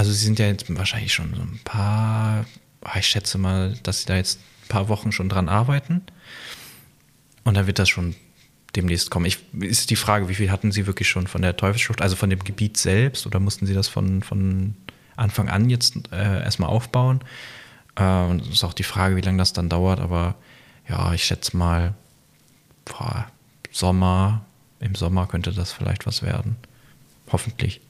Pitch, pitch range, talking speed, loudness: 100 Hz, 95-115 Hz, 185 wpm, -22 LUFS